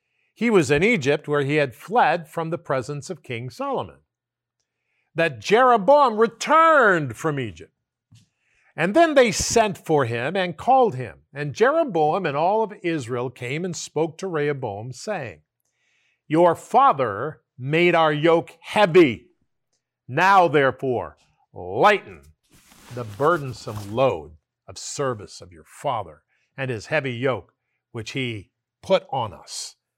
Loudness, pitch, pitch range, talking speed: -21 LUFS, 150 Hz, 125-180 Hz, 130 wpm